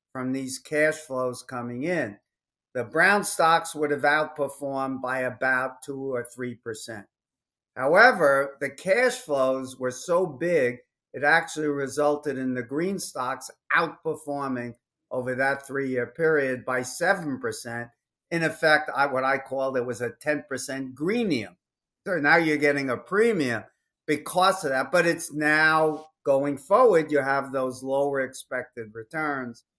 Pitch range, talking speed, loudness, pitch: 130-155 Hz, 140 wpm, -25 LUFS, 140 Hz